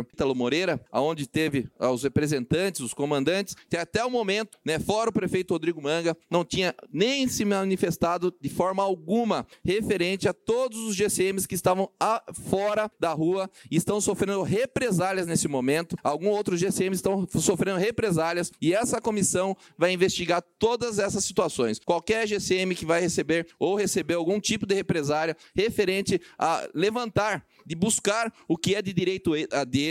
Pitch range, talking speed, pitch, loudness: 170-205 Hz, 160 wpm, 185 Hz, -26 LUFS